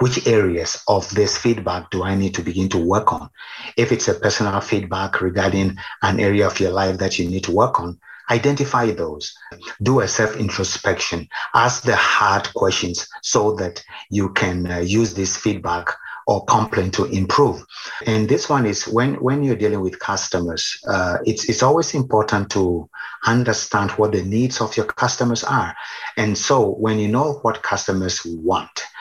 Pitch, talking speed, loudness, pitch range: 105 Hz, 175 wpm, -19 LUFS, 95-115 Hz